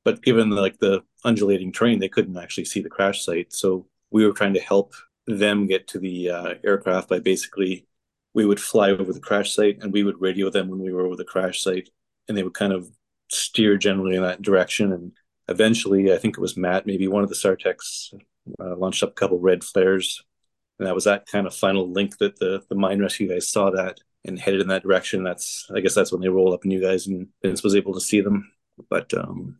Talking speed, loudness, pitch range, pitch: 235 wpm, -22 LUFS, 95-100 Hz, 95 Hz